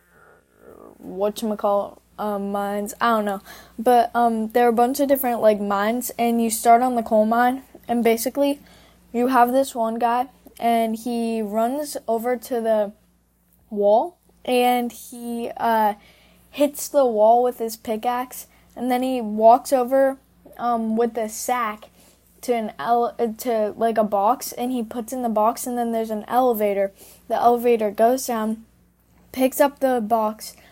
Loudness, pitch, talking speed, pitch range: -21 LUFS, 235 Hz, 160 wpm, 220-245 Hz